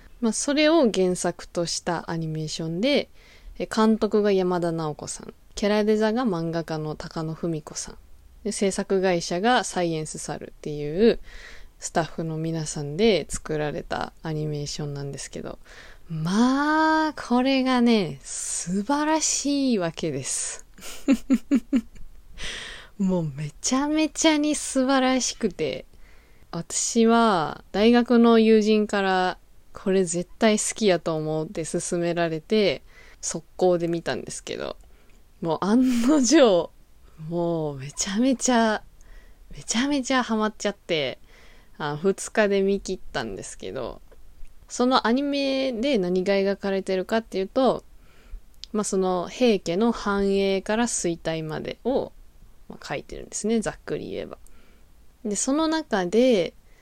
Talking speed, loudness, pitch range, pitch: 255 characters per minute, -24 LUFS, 170-240 Hz, 200 Hz